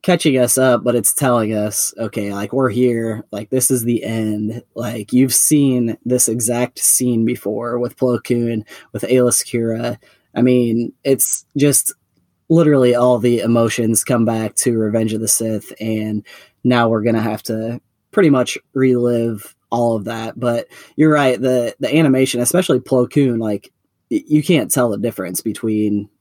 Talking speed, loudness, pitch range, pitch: 170 wpm, -16 LUFS, 110-125 Hz, 120 Hz